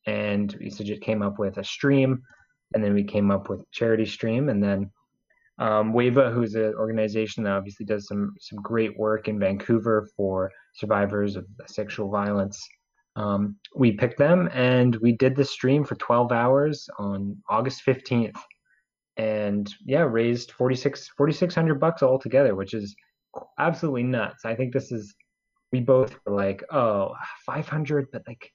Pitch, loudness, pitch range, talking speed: 110 Hz, -25 LUFS, 100-130 Hz, 160 wpm